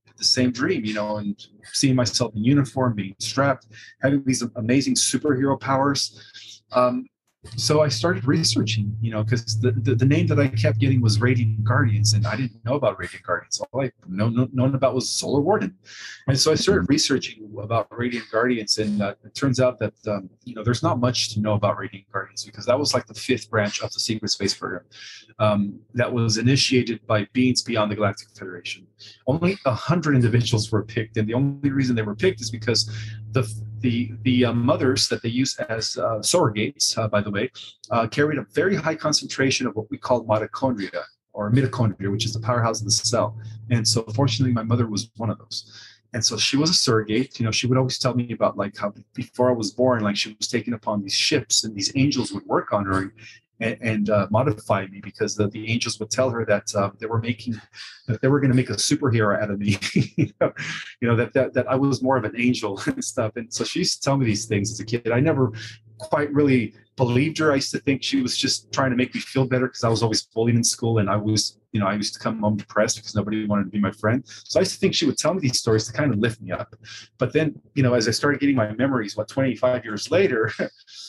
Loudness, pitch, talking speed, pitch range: -22 LUFS, 115 Hz, 240 wpm, 105-130 Hz